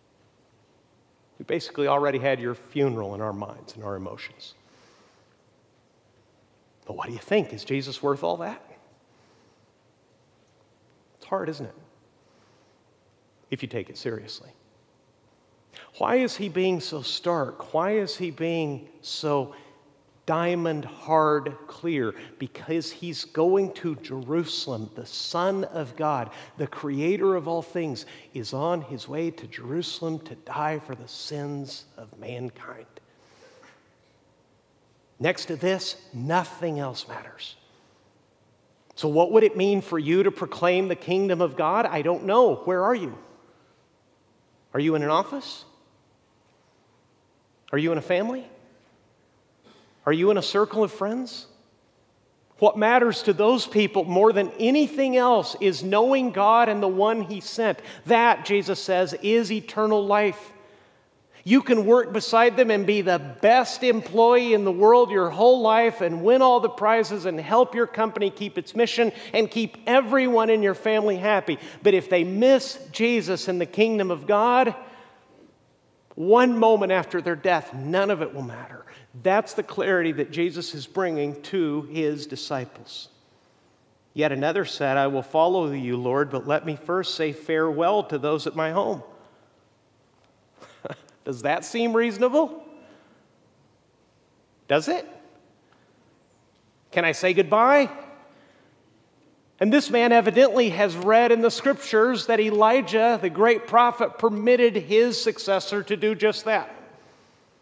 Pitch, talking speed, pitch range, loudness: 185 Hz, 140 wpm, 155-225 Hz, -23 LUFS